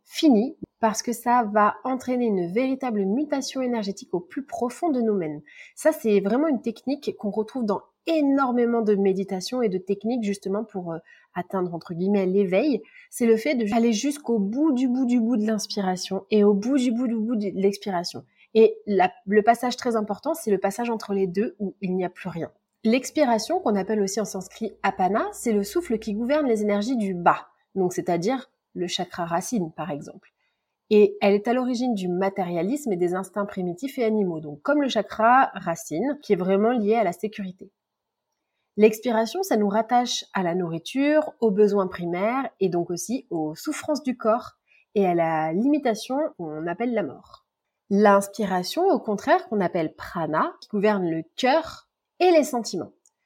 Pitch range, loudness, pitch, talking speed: 190-245 Hz, -24 LUFS, 215 Hz, 180 wpm